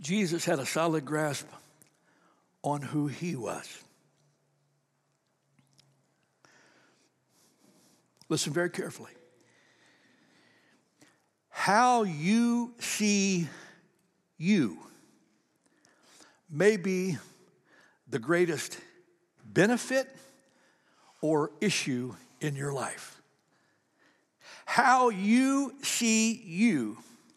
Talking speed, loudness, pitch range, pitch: 65 wpm, -29 LUFS, 150-220 Hz, 175 Hz